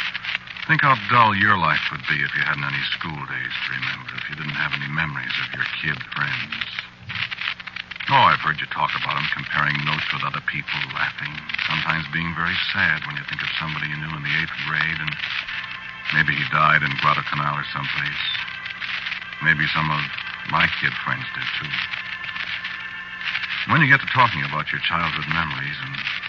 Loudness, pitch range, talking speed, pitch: -22 LUFS, 75-80 Hz, 180 wpm, 75 Hz